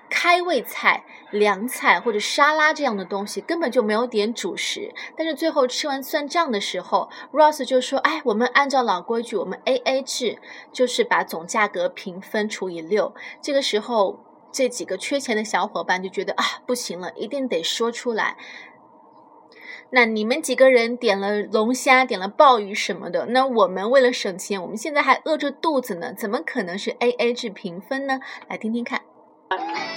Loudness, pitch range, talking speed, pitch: -21 LUFS, 205-280 Hz, 275 characters per minute, 245 Hz